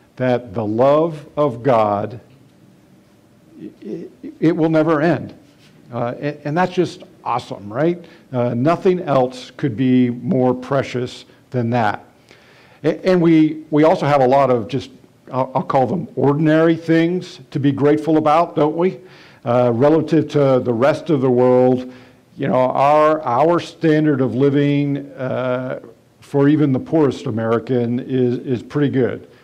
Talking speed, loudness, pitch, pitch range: 150 wpm, -17 LUFS, 140 Hz, 125-155 Hz